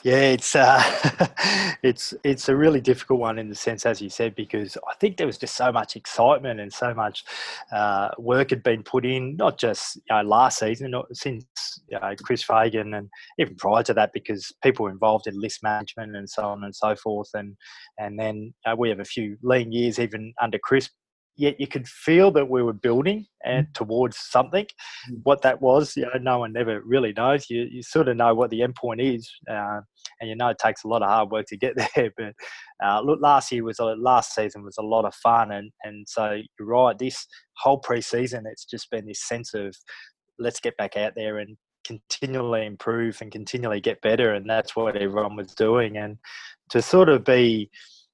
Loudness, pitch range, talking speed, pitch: -23 LUFS, 110-130 Hz, 215 wpm, 115 Hz